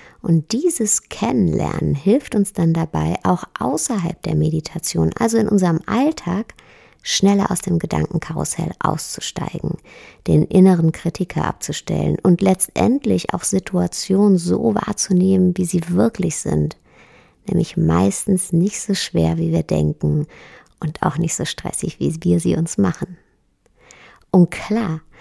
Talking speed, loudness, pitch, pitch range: 130 wpm, -19 LUFS, 180 Hz, 160-200 Hz